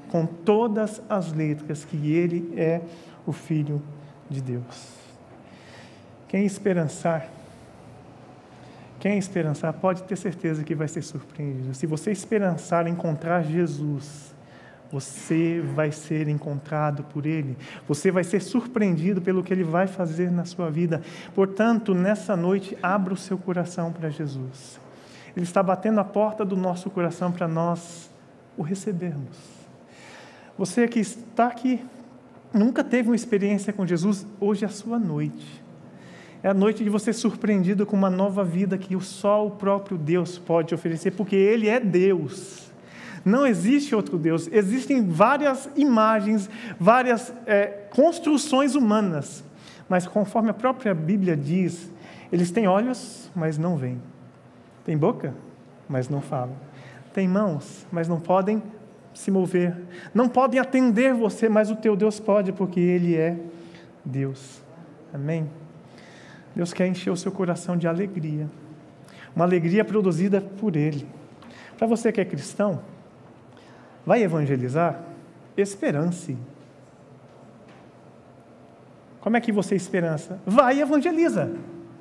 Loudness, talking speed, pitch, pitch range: -24 LUFS, 130 wpm, 180 Hz, 160-210 Hz